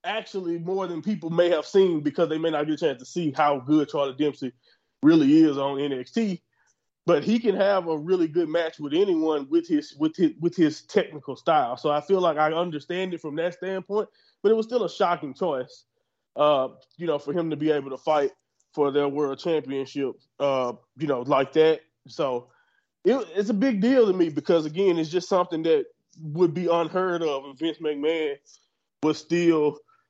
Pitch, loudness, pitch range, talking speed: 170 Hz, -24 LUFS, 150-215 Hz, 200 wpm